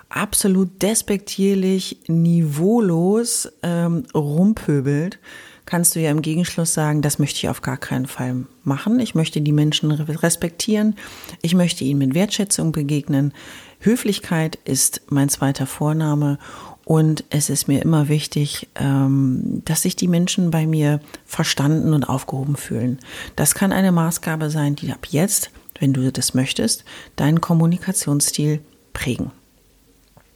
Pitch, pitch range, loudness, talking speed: 155 Hz, 140-175 Hz, -19 LUFS, 130 wpm